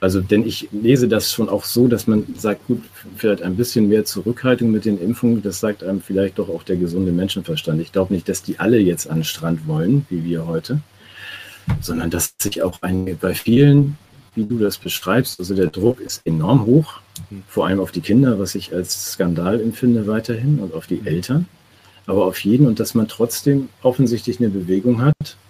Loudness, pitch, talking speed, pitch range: -19 LUFS, 105 Hz, 200 wpm, 95-120 Hz